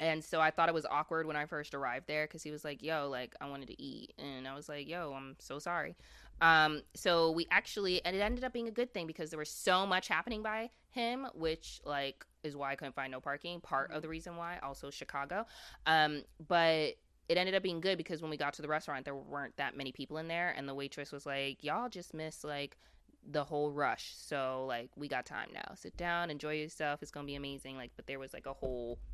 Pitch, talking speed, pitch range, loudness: 155 Hz, 250 wpm, 140-170 Hz, -37 LUFS